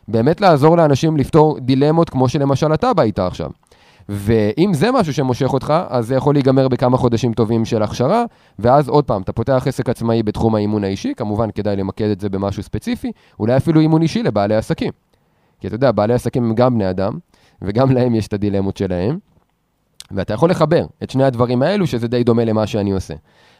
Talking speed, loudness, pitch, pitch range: 195 wpm, -16 LUFS, 120 Hz, 105-145 Hz